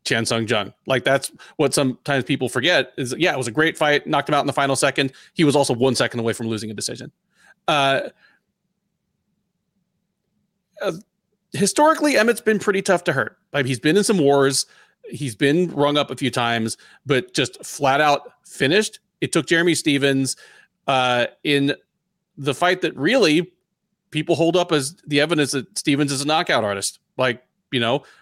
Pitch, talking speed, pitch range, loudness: 145 Hz, 180 wpm, 135-185 Hz, -20 LUFS